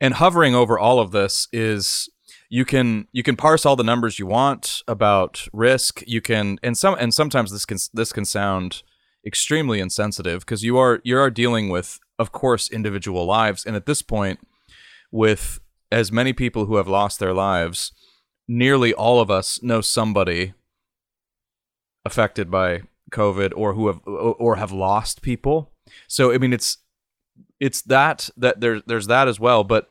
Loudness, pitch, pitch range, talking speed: -20 LUFS, 110 Hz, 100-125 Hz, 170 wpm